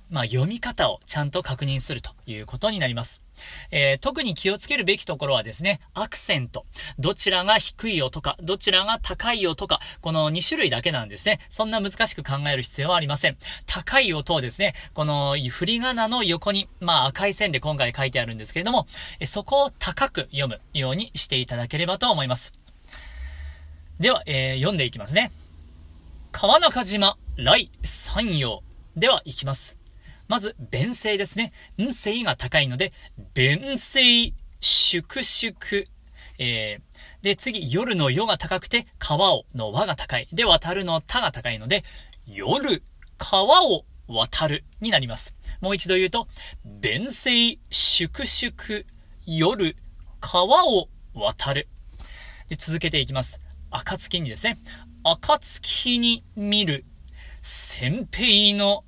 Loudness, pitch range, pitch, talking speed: -21 LUFS, 130-205 Hz, 165 Hz, 270 characters per minute